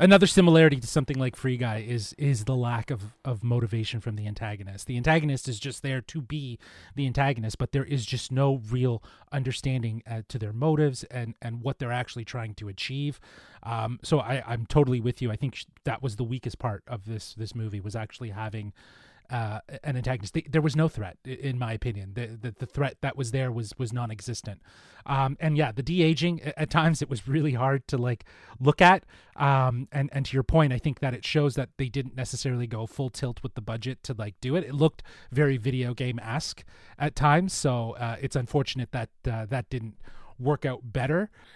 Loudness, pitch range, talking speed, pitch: -28 LUFS, 115-140 Hz, 210 wpm, 130 Hz